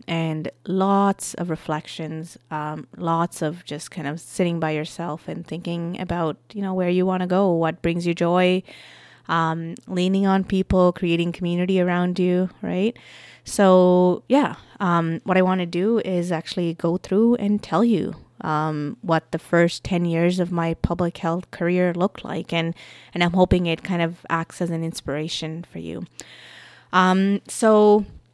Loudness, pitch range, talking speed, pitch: -22 LUFS, 165-185 Hz, 165 wpm, 175 Hz